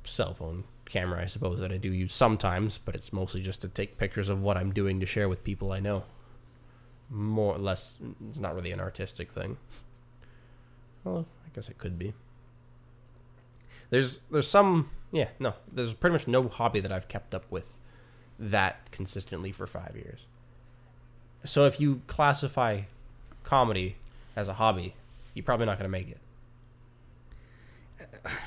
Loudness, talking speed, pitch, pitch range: -30 LUFS, 160 wpm, 120 Hz, 95-120 Hz